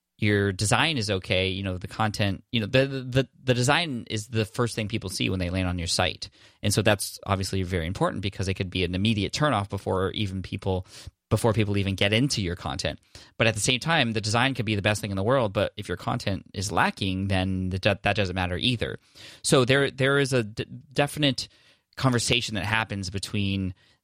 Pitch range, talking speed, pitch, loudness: 95-120 Hz, 215 wpm, 105 Hz, -26 LUFS